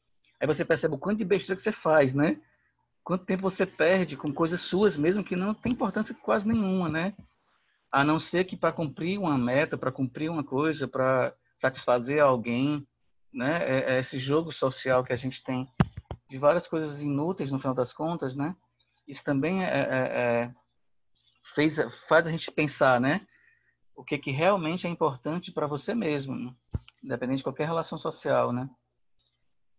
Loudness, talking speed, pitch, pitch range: -28 LUFS, 175 wpm, 150 Hz, 130-175 Hz